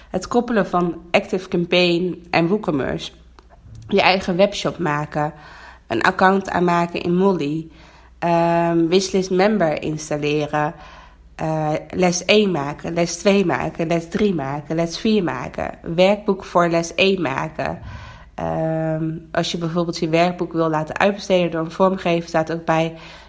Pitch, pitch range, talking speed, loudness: 170 Hz, 160-185 Hz, 135 wpm, -20 LUFS